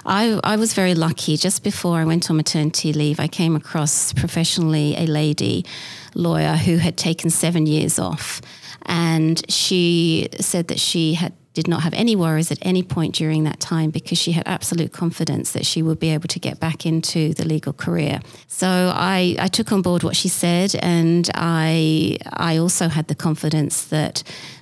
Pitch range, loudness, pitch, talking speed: 155-175 Hz, -19 LUFS, 165 Hz, 185 wpm